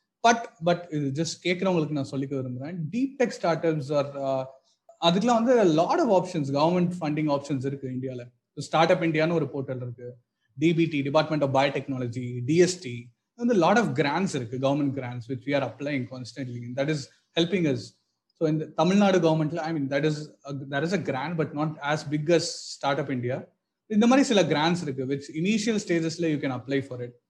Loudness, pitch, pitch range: -26 LUFS, 150 Hz, 135-170 Hz